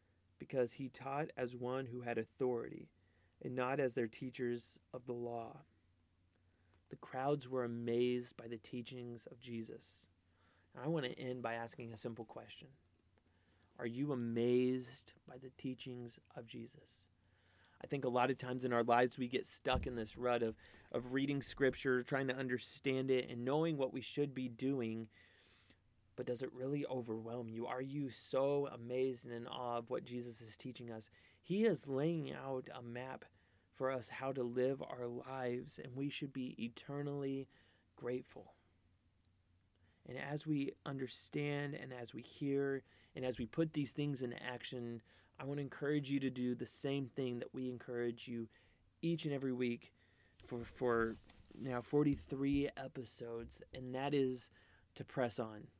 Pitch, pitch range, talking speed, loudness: 125 Hz, 115-135 Hz, 170 wpm, -42 LUFS